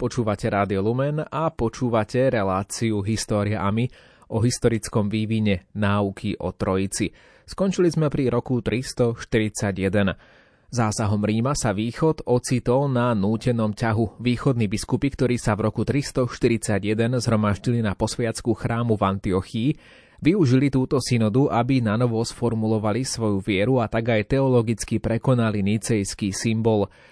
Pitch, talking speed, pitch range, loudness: 115 Hz, 120 wpm, 105-125 Hz, -23 LUFS